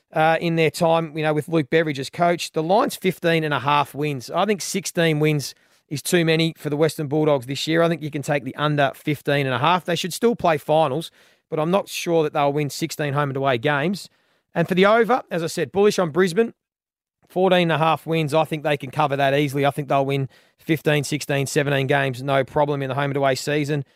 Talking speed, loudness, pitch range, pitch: 245 wpm, -21 LUFS, 145-165 Hz, 155 Hz